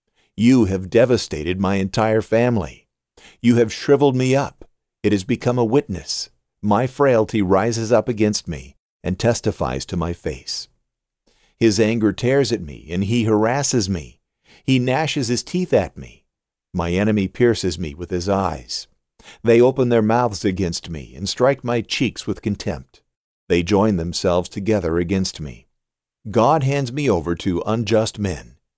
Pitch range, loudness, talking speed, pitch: 90-120 Hz, -20 LUFS, 155 wpm, 105 Hz